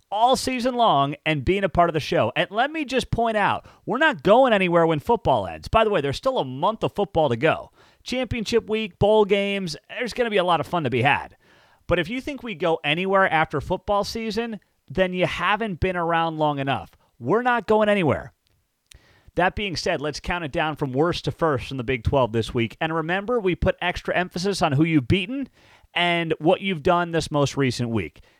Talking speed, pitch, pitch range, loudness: 220 wpm, 175 Hz, 155-215 Hz, -22 LUFS